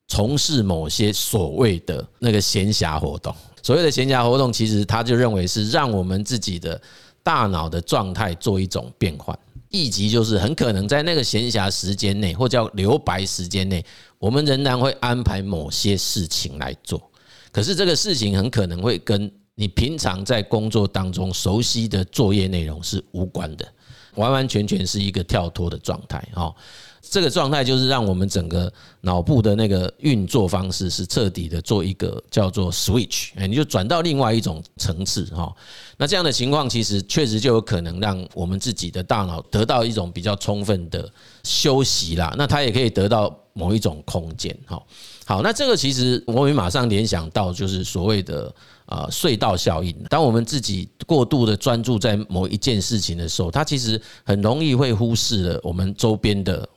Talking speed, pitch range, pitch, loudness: 285 characters per minute, 95-120 Hz, 105 Hz, -21 LUFS